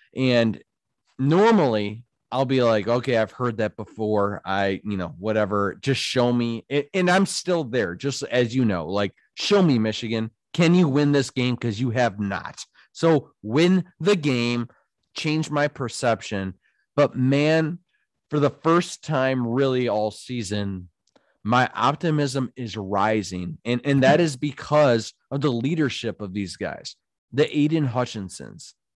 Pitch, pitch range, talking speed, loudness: 125 Hz, 110-150 Hz, 150 wpm, -23 LUFS